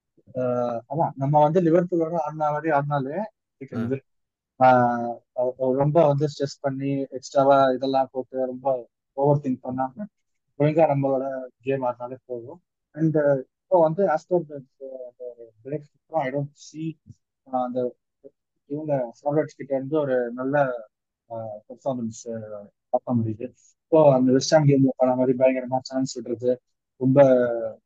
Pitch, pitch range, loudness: 135 Hz, 125-145 Hz, -23 LUFS